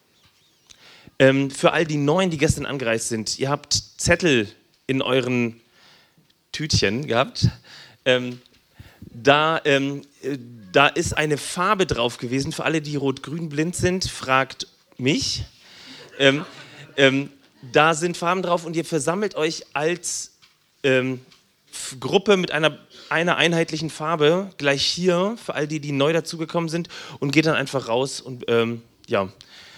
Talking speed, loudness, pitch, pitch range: 135 wpm, -22 LUFS, 145 Hz, 130-165 Hz